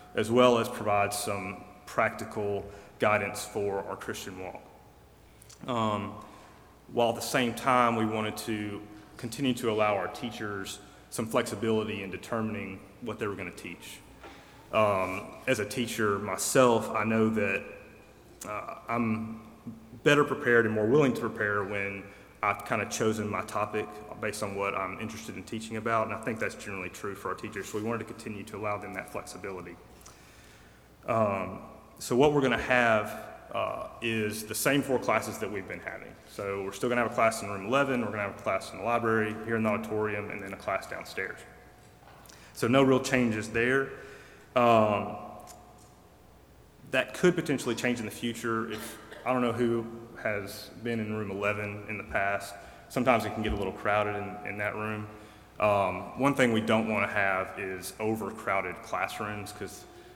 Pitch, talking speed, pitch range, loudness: 110 Hz, 180 wpm, 100-115 Hz, -30 LUFS